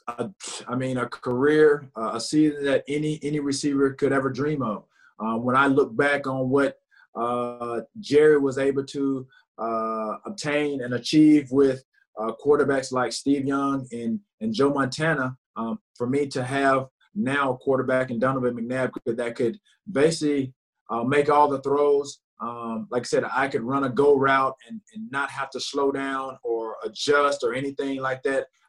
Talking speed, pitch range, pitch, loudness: 175 wpm, 125-145 Hz, 135 Hz, -24 LUFS